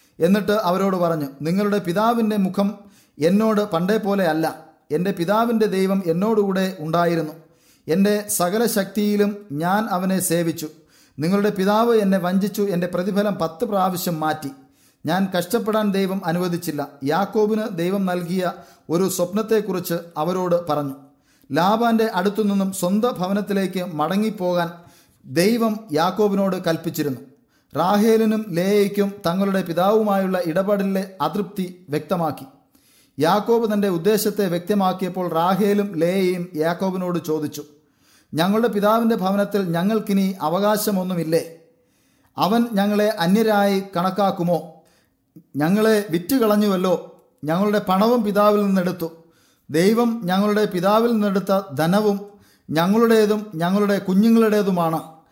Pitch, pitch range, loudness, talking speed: 190 Hz, 165-210 Hz, -20 LUFS, 95 wpm